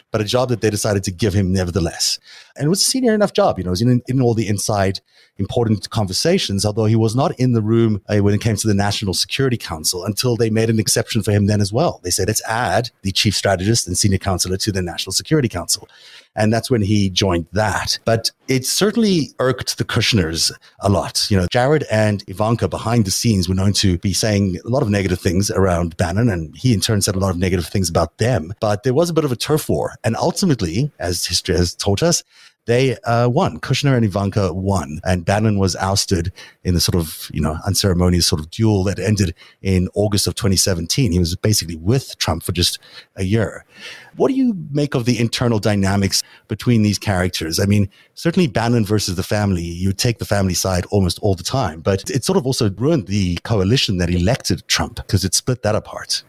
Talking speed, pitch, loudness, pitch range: 220 wpm, 105 Hz, -18 LUFS, 95-120 Hz